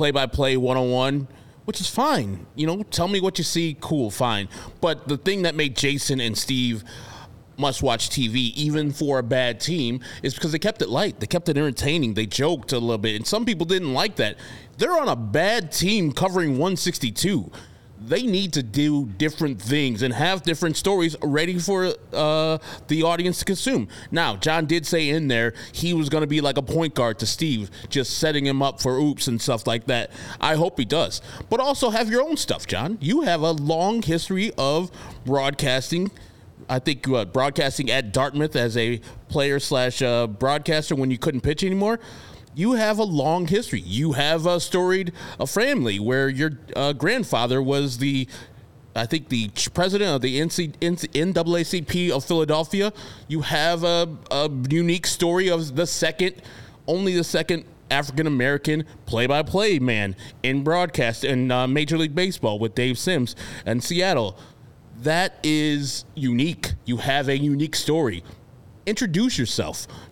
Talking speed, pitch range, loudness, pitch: 175 wpm, 125-170 Hz, -23 LUFS, 145 Hz